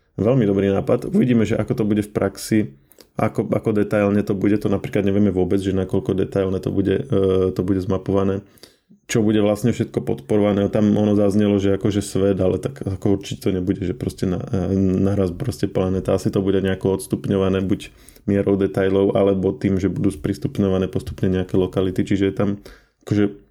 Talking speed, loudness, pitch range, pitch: 185 wpm, -20 LUFS, 95-105 Hz, 100 Hz